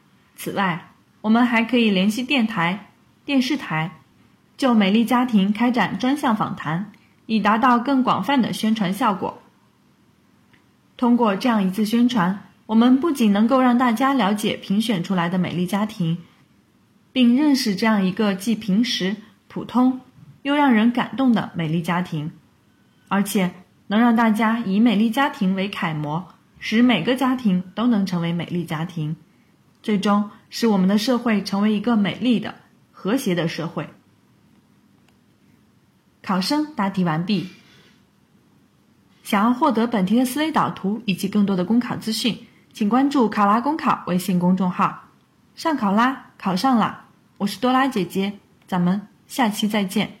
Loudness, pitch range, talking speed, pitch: -20 LUFS, 190-240 Hz, 225 characters per minute, 215 Hz